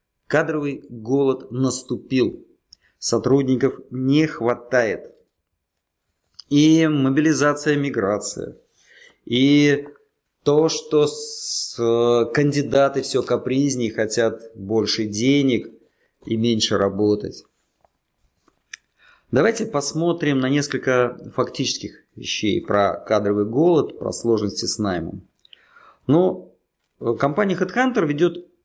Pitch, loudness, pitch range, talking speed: 130 Hz, -20 LUFS, 115-145 Hz, 80 wpm